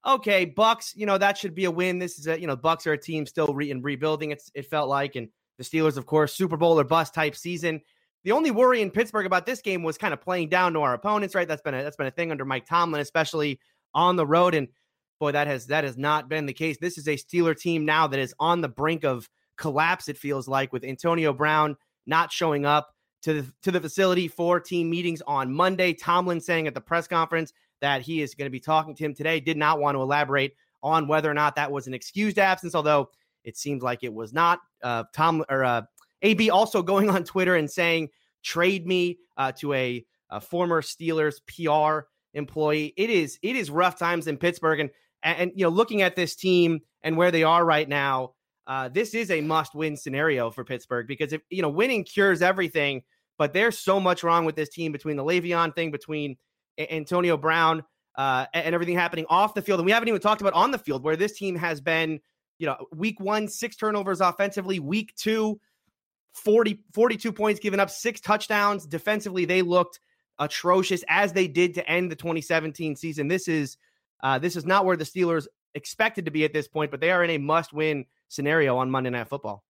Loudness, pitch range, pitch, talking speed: -25 LUFS, 150-180 Hz, 160 Hz, 225 wpm